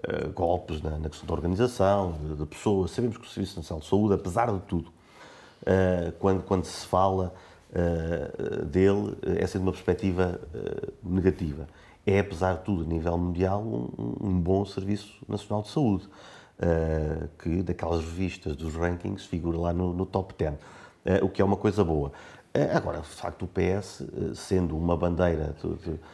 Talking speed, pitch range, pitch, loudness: 175 wpm, 85-95 Hz, 90 Hz, -28 LUFS